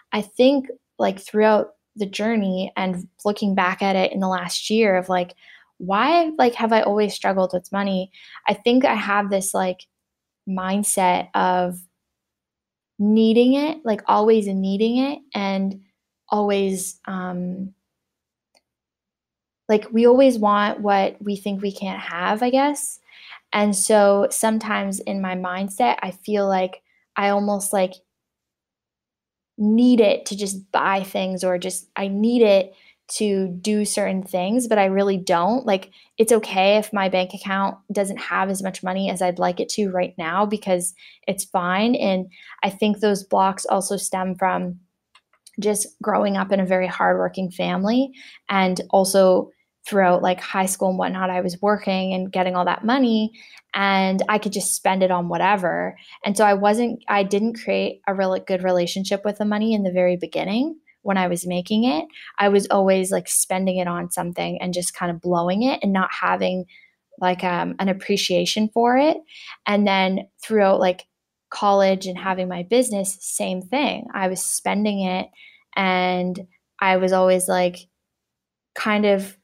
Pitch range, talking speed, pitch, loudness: 185-210 Hz, 160 wpm, 195 Hz, -21 LUFS